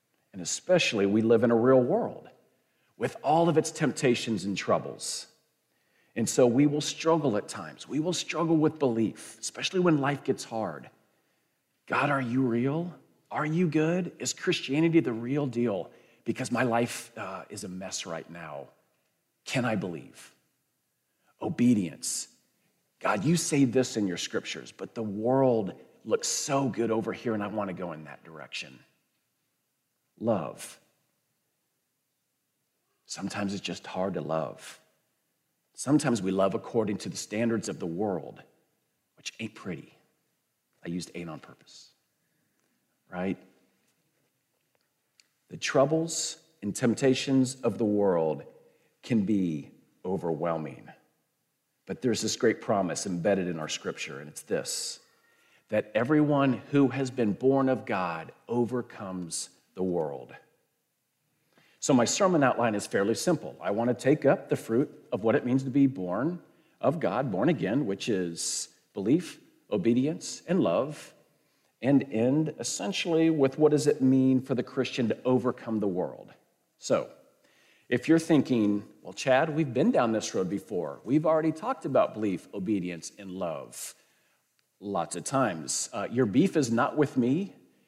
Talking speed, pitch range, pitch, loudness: 145 wpm, 110-150 Hz, 130 Hz, -28 LUFS